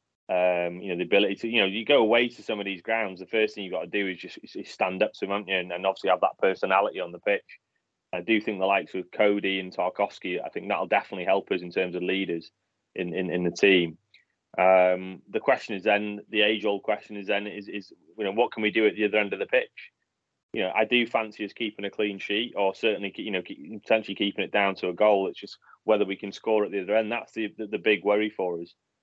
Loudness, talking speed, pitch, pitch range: -26 LUFS, 270 wpm, 100 Hz, 95-110 Hz